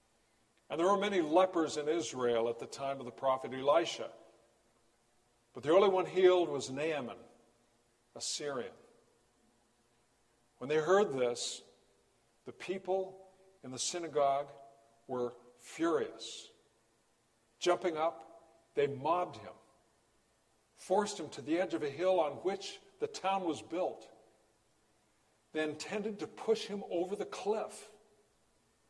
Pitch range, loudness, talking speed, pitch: 115-170 Hz, -34 LUFS, 125 wpm, 125 Hz